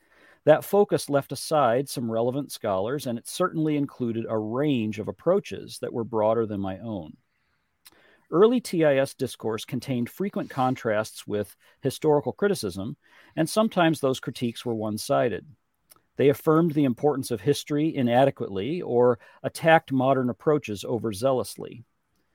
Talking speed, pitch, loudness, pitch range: 130 wpm, 135 Hz, -25 LUFS, 115-150 Hz